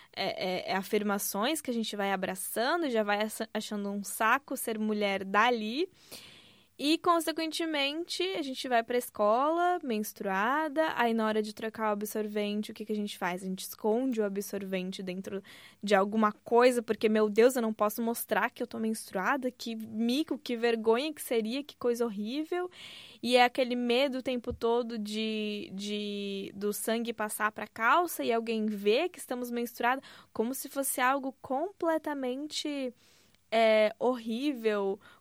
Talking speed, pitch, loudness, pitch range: 165 wpm, 230 Hz, -31 LUFS, 210-265 Hz